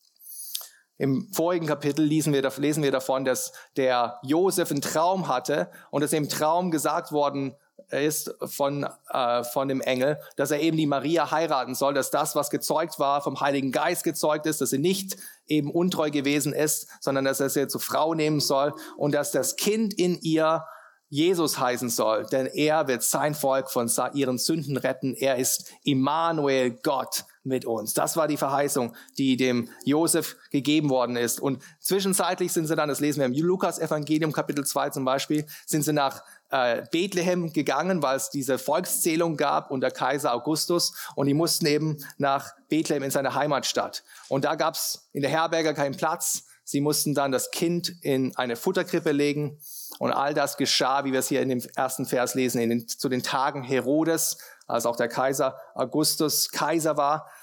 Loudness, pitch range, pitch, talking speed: -25 LUFS, 135-155 Hz, 145 Hz, 180 wpm